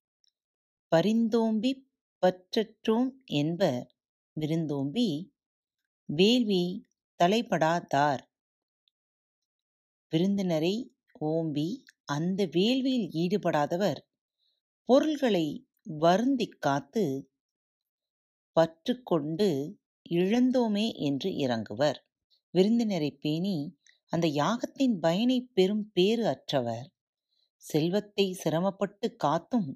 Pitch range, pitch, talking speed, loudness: 155-225 Hz, 185 Hz, 60 wpm, -28 LUFS